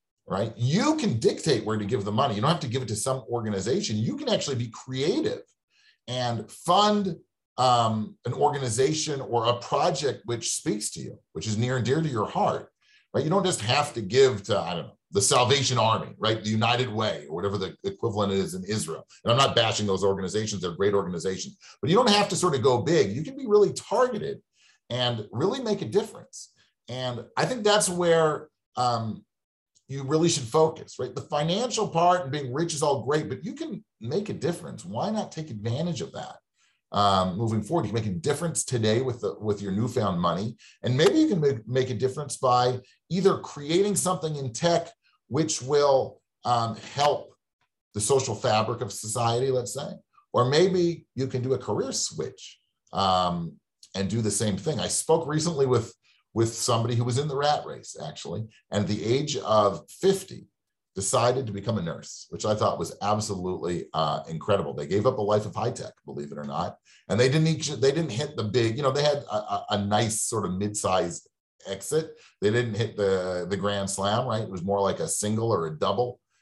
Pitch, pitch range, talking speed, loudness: 125 Hz, 105-150 Hz, 205 wpm, -26 LUFS